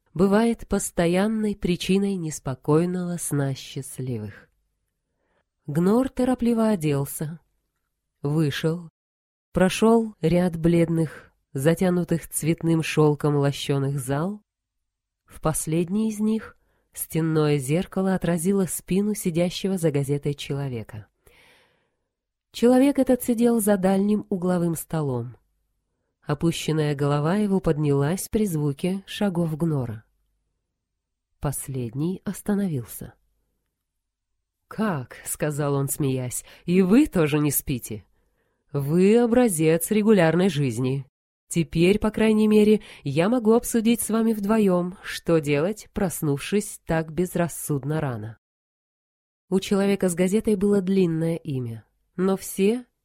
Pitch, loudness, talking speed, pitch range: 170 Hz, -23 LUFS, 95 wpm, 145-200 Hz